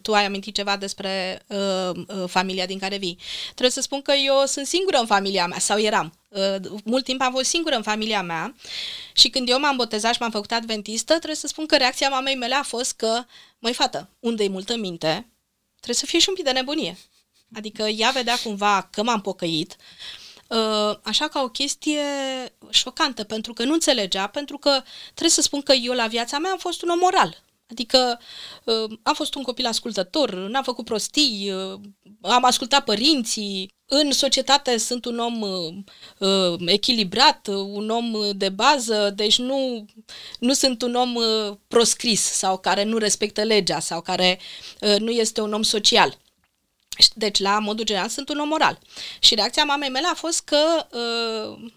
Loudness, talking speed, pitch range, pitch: -21 LUFS, 175 wpm, 205-270 Hz, 230 Hz